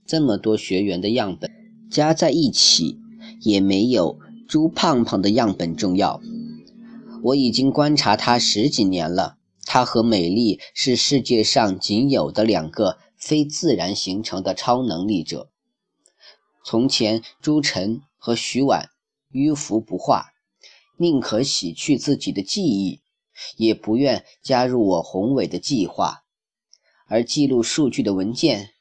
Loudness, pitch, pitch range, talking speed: -20 LUFS, 125 Hz, 110-155 Hz, 200 characters per minute